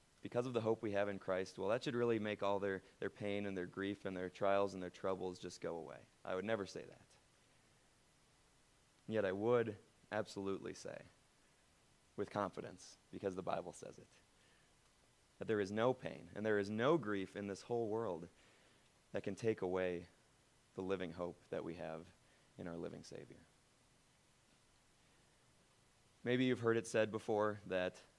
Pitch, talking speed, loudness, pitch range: 100 Hz, 175 wpm, -41 LUFS, 95-110 Hz